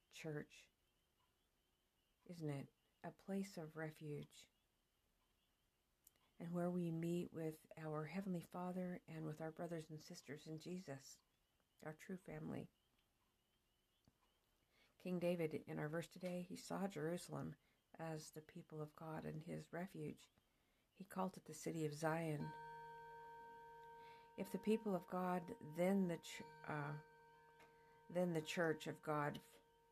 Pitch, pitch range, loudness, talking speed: 155 Hz, 155-175 Hz, -48 LUFS, 125 wpm